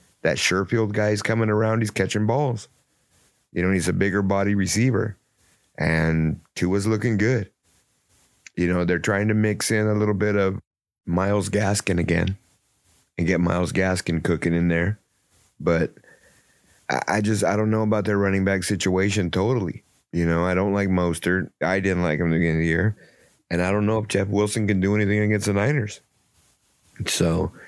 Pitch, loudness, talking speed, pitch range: 100 Hz, -22 LUFS, 180 wpm, 90-105 Hz